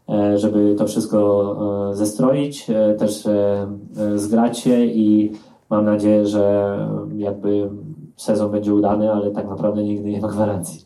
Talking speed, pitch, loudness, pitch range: 120 wpm, 105 Hz, -19 LUFS, 100-105 Hz